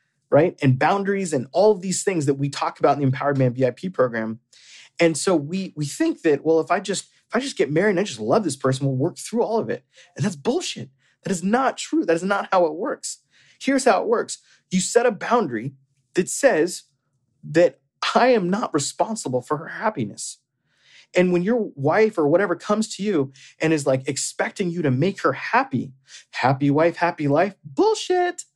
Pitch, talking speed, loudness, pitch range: 175 Hz, 210 wpm, -22 LUFS, 140-215 Hz